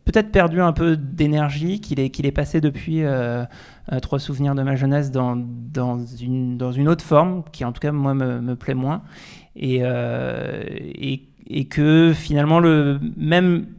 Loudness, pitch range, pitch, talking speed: -20 LUFS, 130-160 Hz, 140 Hz, 180 wpm